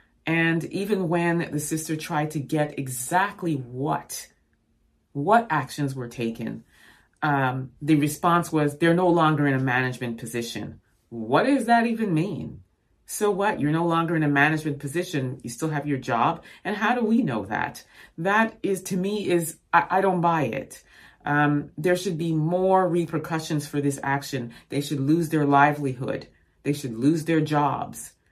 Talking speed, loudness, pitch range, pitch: 165 wpm, -24 LUFS, 140-170 Hz, 155 Hz